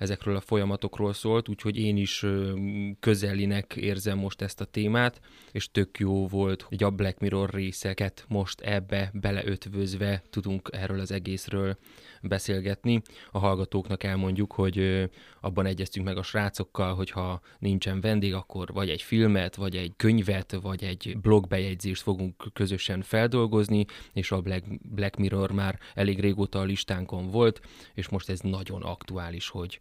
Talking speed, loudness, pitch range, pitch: 150 wpm, -29 LUFS, 95-100 Hz, 100 Hz